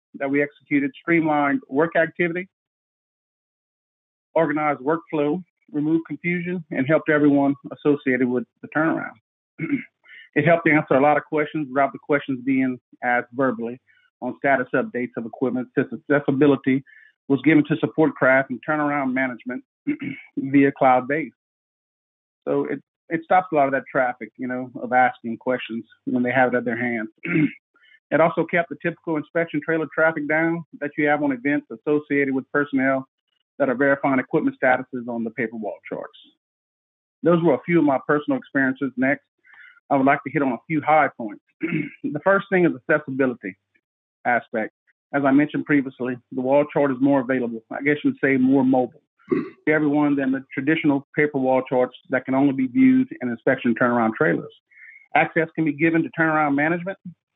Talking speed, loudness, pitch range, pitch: 170 wpm, -22 LUFS, 130-160 Hz, 145 Hz